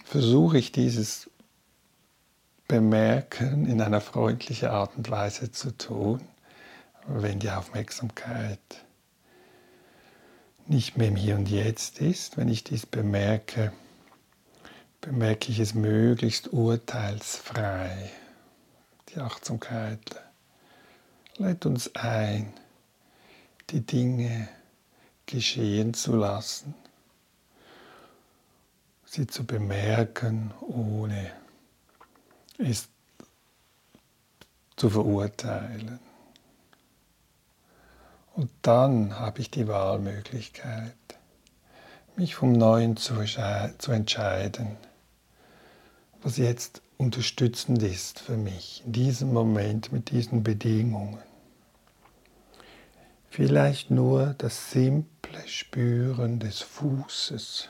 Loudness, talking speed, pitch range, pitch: -27 LUFS, 80 wpm, 105-125 Hz, 115 Hz